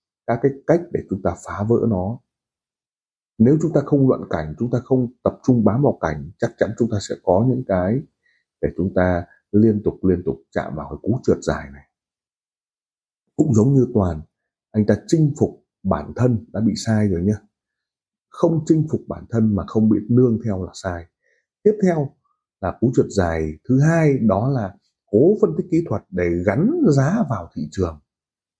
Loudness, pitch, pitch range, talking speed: -20 LUFS, 110 Hz, 90-135 Hz, 195 wpm